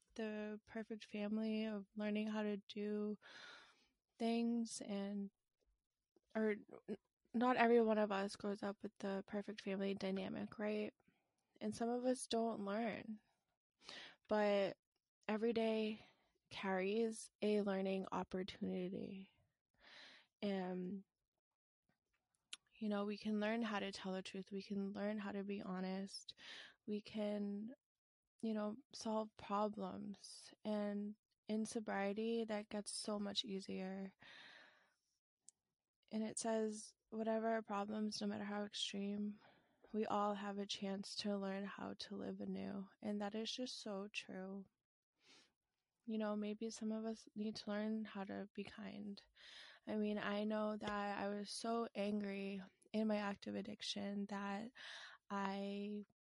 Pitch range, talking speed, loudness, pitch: 200-220 Hz, 130 wpm, -44 LUFS, 210 Hz